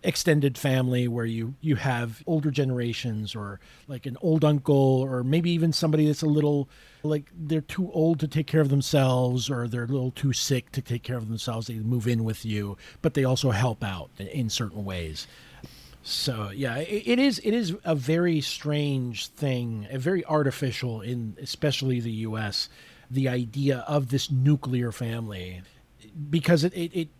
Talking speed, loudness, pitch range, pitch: 180 wpm, -26 LUFS, 120-150 Hz, 135 Hz